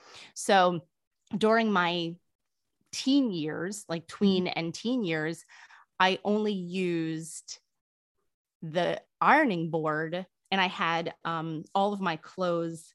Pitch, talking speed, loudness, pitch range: 175 Hz, 110 wpm, -28 LUFS, 165-200 Hz